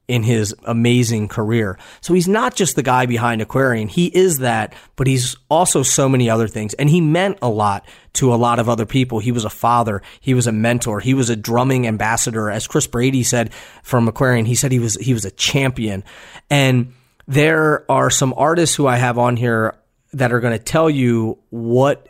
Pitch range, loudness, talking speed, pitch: 115-135 Hz, -17 LUFS, 205 wpm, 120 Hz